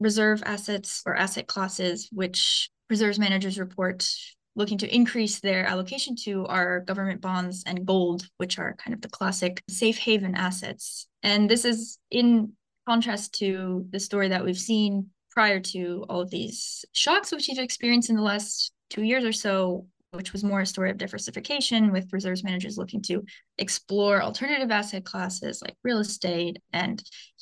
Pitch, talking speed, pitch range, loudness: 200 Hz, 165 wpm, 185-220 Hz, -26 LUFS